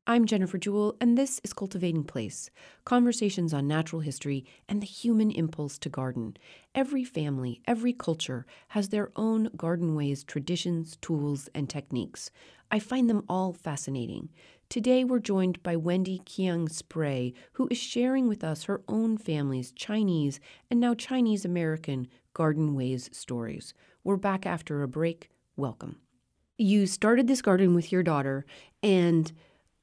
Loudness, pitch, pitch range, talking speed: -29 LUFS, 175 Hz, 145-215 Hz, 145 wpm